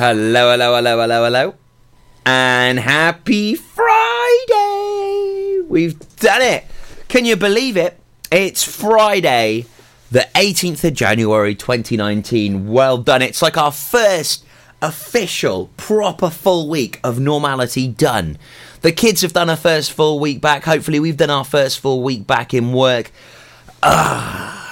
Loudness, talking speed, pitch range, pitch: -15 LUFS, 135 wpm, 125-190 Hz, 145 Hz